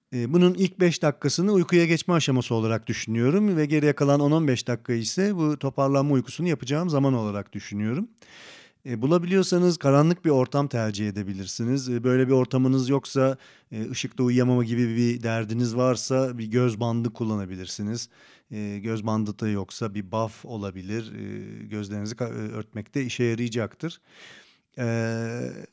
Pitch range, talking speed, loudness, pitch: 110-140 Hz, 125 wpm, -25 LUFS, 125 Hz